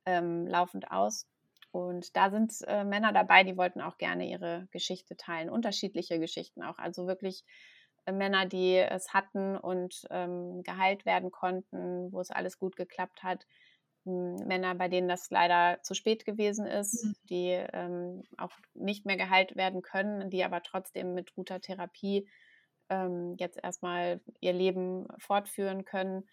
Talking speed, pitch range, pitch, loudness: 155 wpm, 180-195 Hz, 185 Hz, -32 LUFS